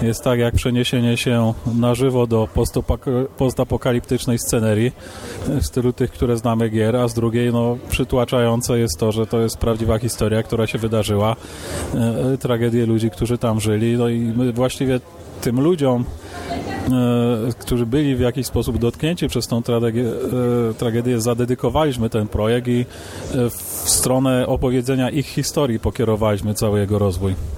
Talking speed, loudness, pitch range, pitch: 150 wpm, -19 LUFS, 110-125 Hz, 120 Hz